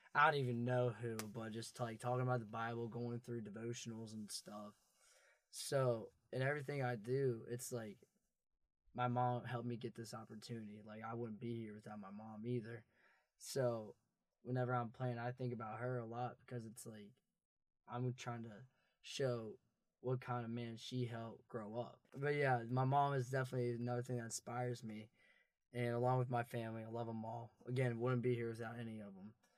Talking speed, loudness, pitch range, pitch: 190 wpm, -43 LUFS, 115-125 Hz, 120 Hz